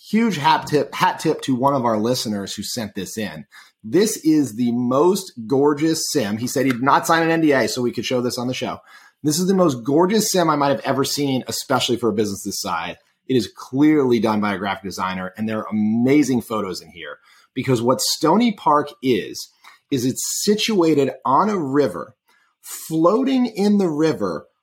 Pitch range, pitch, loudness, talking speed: 120-160 Hz, 135 Hz, -19 LUFS, 200 wpm